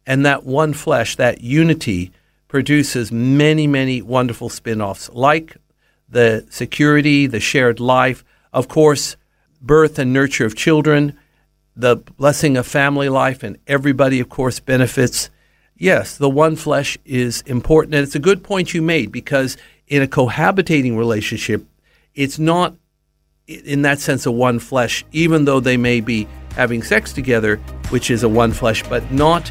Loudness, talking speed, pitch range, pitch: -16 LUFS, 155 wpm, 120-150 Hz, 135 Hz